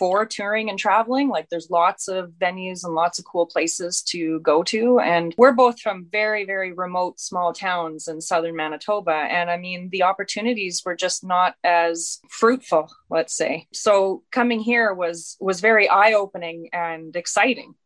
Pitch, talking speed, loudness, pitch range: 180 Hz, 170 wpm, -21 LUFS, 170-210 Hz